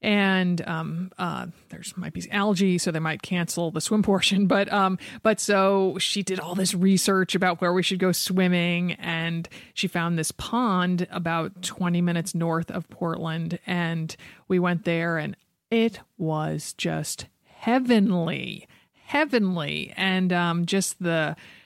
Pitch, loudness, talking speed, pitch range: 180 Hz, -25 LUFS, 150 wpm, 170-195 Hz